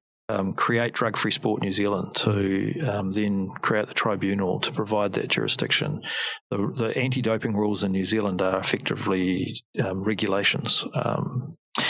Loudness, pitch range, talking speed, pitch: -24 LUFS, 95-110 Hz, 150 wpm, 100 Hz